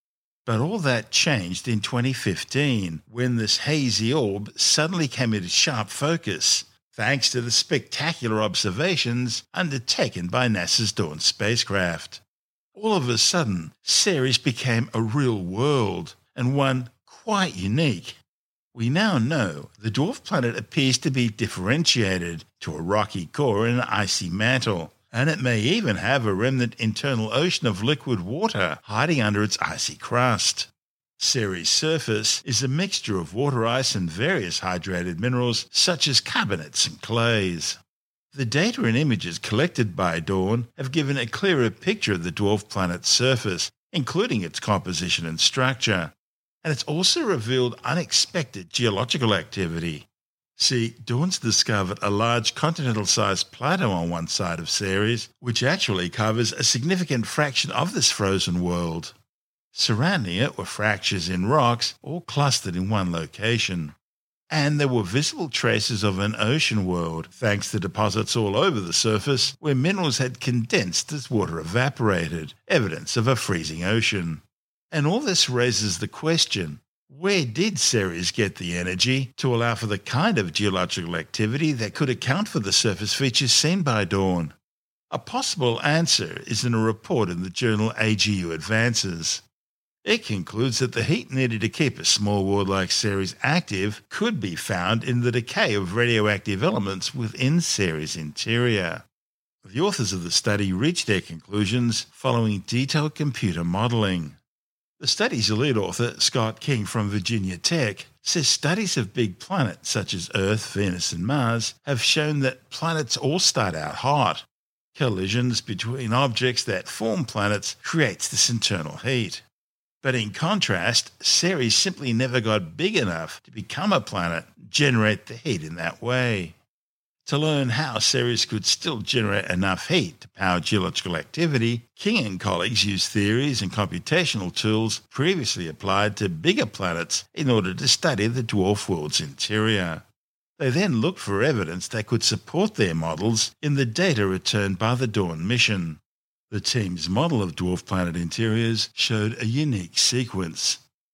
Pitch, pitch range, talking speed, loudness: 115 Hz, 100-130 Hz, 150 wpm, -23 LUFS